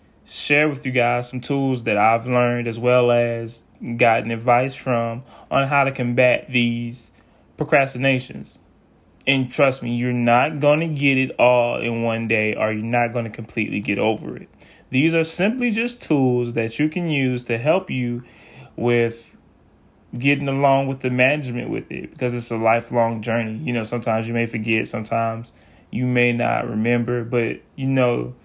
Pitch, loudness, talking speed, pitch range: 120 Hz, -20 LUFS, 175 wpm, 115-130 Hz